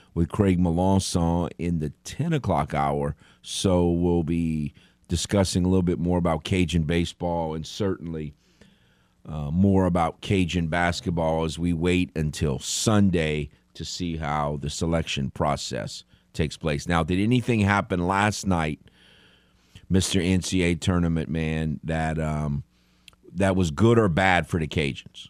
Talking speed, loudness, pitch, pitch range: 140 wpm, -24 LUFS, 85 Hz, 80-95 Hz